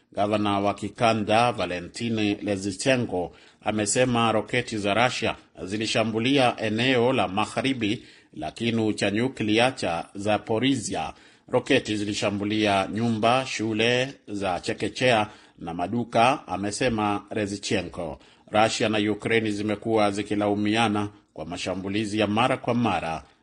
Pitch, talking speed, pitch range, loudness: 105 Hz, 100 wpm, 100-115 Hz, -25 LUFS